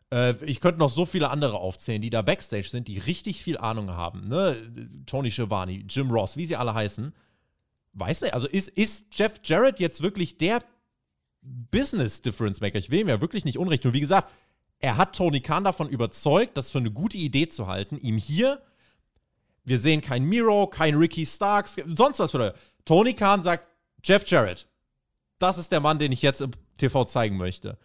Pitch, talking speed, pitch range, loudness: 145 Hz, 195 wpm, 115-180 Hz, -25 LUFS